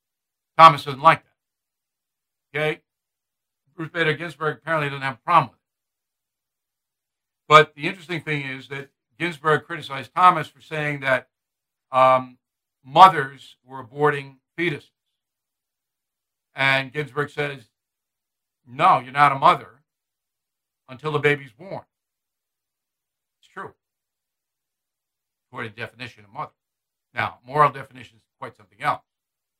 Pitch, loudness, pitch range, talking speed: 145 Hz, -20 LUFS, 130-155 Hz, 120 wpm